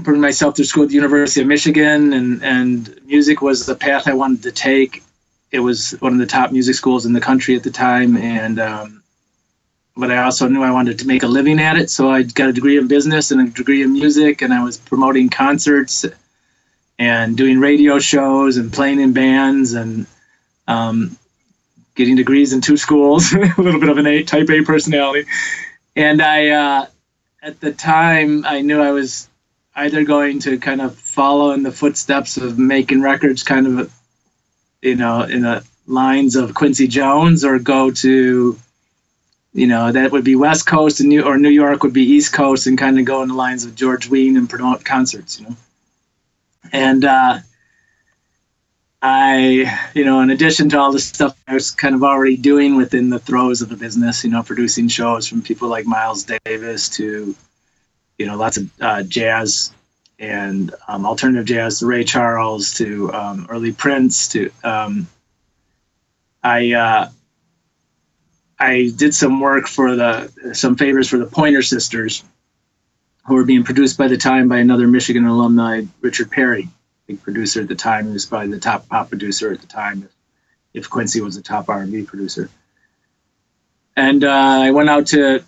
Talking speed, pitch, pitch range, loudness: 185 wpm, 130 Hz, 120-140 Hz, -14 LUFS